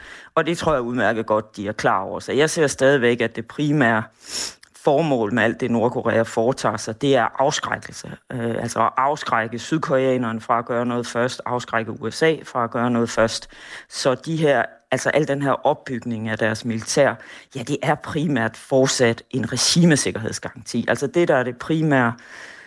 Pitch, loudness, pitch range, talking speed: 120 Hz, -21 LUFS, 115-135 Hz, 175 wpm